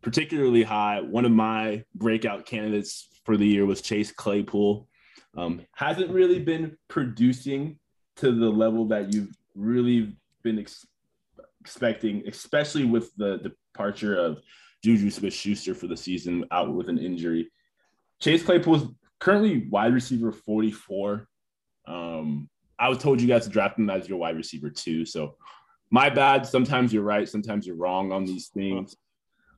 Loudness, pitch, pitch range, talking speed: -25 LUFS, 110 Hz, 100-130 Hz, 150 wpm